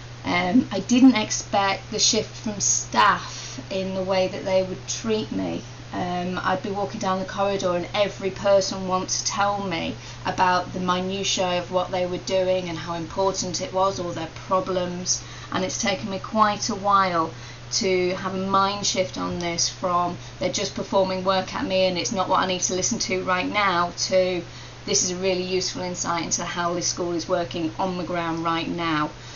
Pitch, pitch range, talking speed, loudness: 185 Hz, 170-190 Hz, 195 wpm, -23 LUFS